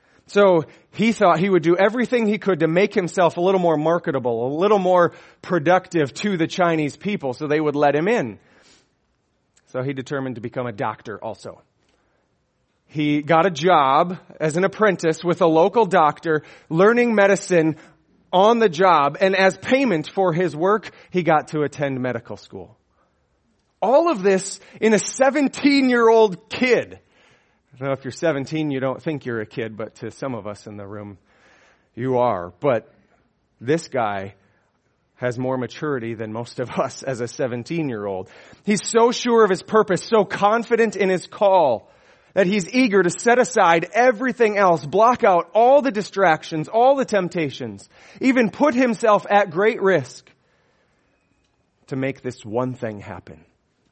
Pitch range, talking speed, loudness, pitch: 135-205 Hz, 165 wpm, -19 LUFS, 170 Hz